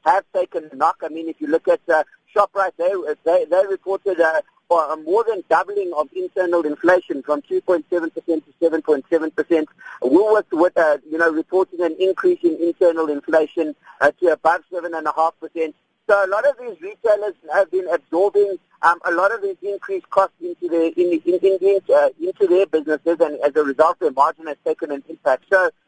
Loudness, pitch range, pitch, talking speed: -19 LUFS, 160-205 Hz, 175 Hz, 195 wpm